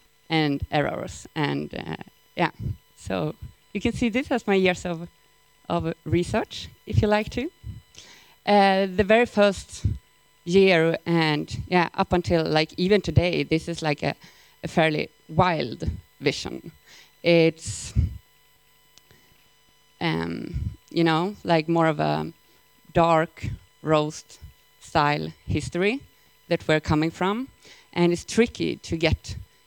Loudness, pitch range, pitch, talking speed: -24 LUFS, 140-190 Hz, 165 Hz, 125 wpm